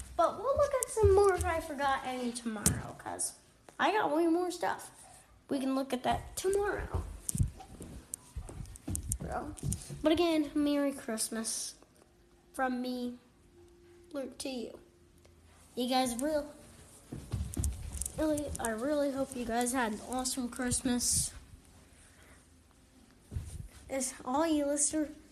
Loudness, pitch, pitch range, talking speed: -33 LUFS, 265 Hz, 235-300 Hz, 115 wpm